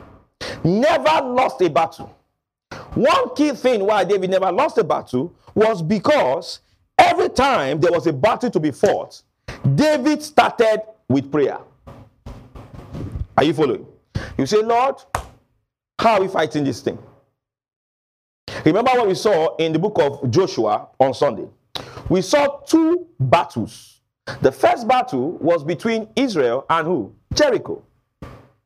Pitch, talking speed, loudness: 210 Hz, 135 wpm, -18 LUFS